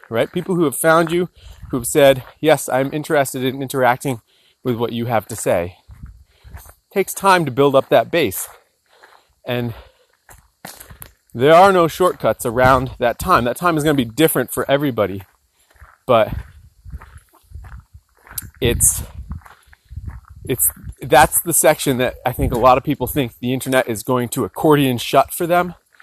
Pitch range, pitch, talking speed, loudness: 115-150 Hz, 130 Hz, 155 wpm, -17 LUFS